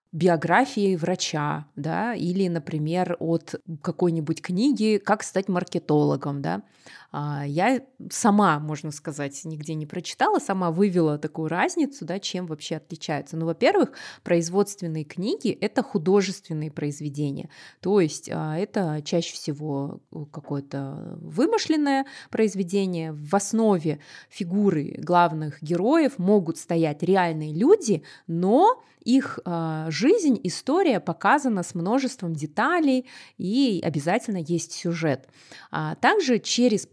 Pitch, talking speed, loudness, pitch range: 175 Hz, 105 wpm, -24 LUFS, 160-210 Hz